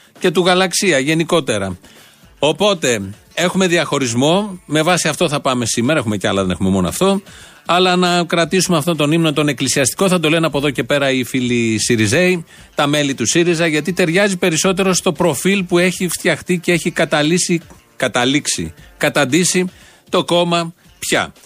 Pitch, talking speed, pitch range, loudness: 165 Hz, 160 wpm, 140-180 Hz, -15 LUFS